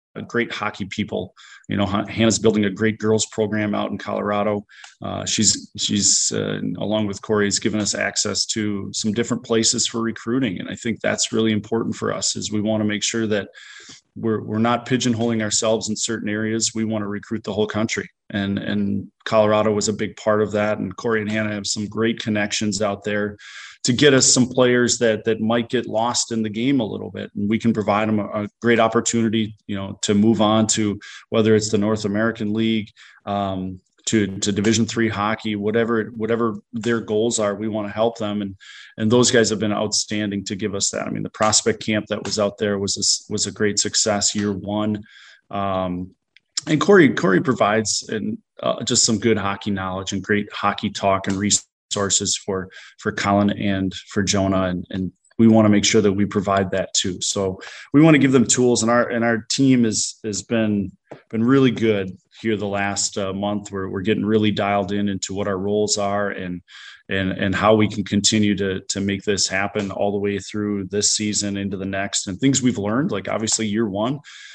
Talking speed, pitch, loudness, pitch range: 210 wpm, 105 Hz, -20 LUFS, 100-110 Hz